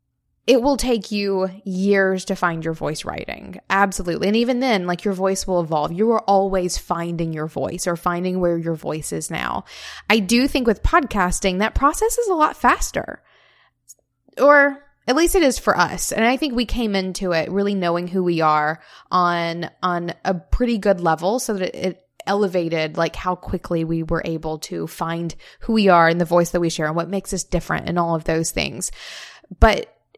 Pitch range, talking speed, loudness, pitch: 170-215 Hz, 200 wpm, -20 LUFS, 185 Hz